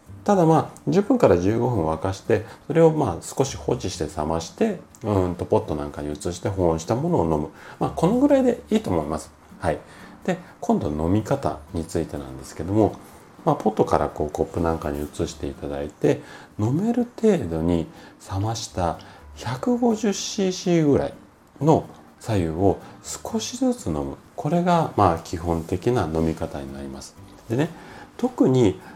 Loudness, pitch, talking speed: -23 LUFS, 90 Hz, 315 characters per minute